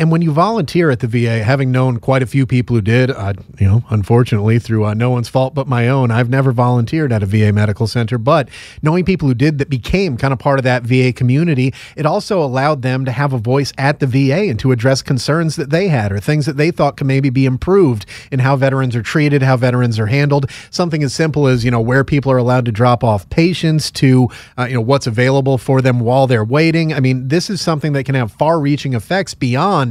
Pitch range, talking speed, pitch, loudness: 125-150 Hz, 245 wpm, 135 Hz, -14 LUFS